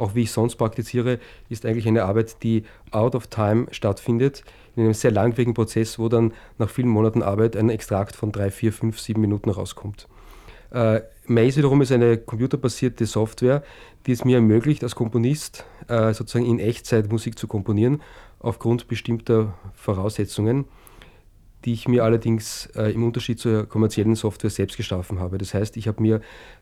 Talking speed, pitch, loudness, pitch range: 170 wpm, 115 Hz, -22 LUFS, 110-120 Hz